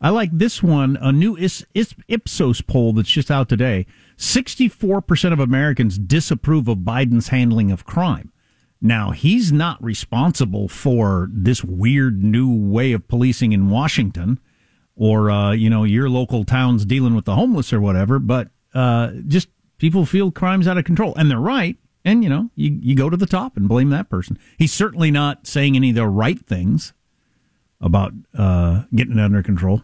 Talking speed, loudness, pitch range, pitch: 175 wpm, -18 LUFS, 110-155 Hz, 125 Hz